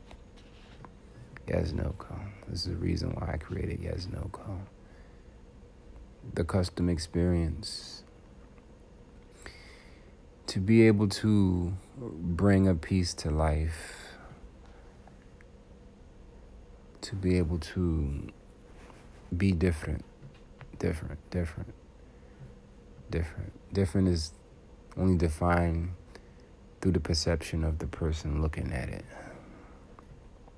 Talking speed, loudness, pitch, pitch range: 90 wpm, -31 LUFS, 90 Hz, 80-95 Hz